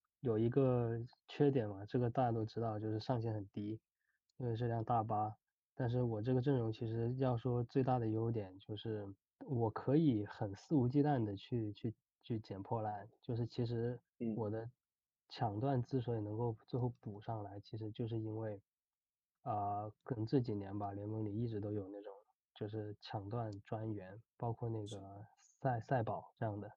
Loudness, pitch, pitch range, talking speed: -40 LUFS, 115 Hz, 105-120 Hz, 260 characters per minute